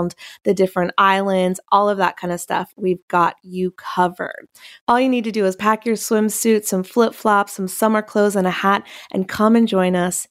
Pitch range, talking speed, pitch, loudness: 185-220 Hz, 210 wpm, 200 Hz, -18 LUFS